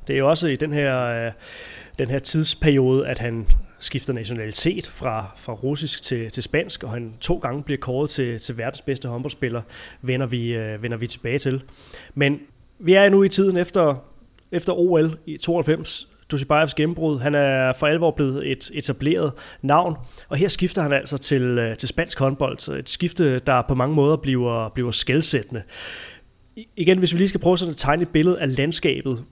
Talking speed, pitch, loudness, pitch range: 180 wpm, 140 Hz, -22 LUFS, 125-160 Hz